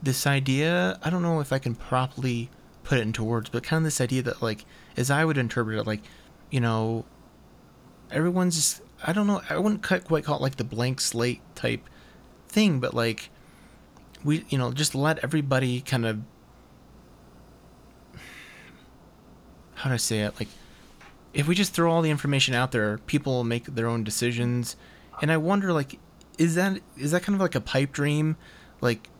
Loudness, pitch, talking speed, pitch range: -26 LUFS, 135 Hz, 185 wpm, 120-160 Hz